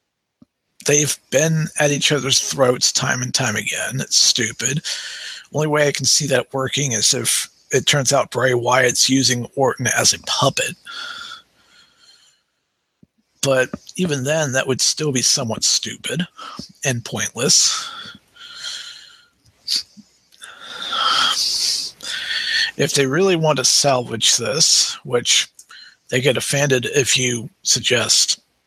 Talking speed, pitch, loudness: 115 wpm, 145 Hz, -17 LUFS